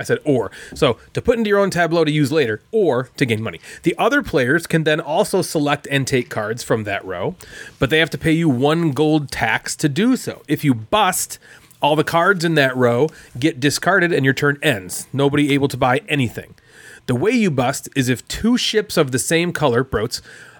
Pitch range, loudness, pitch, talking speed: 135-165 Hz, -18 LUFS, 150 Hz, 220 wpm